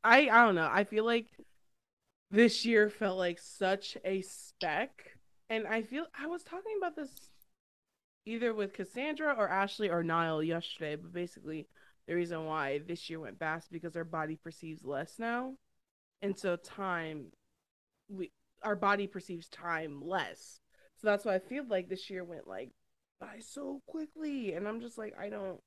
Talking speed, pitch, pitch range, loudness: 170 wpm, 195 Hz, 170-230 Hz, -34 LUFS